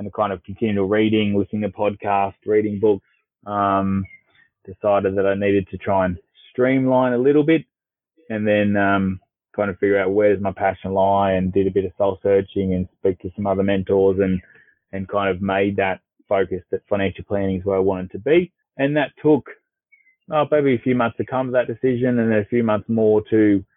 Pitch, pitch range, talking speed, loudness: 100 Hz, 95-115 Hz, 210 wpm, -20 LUFS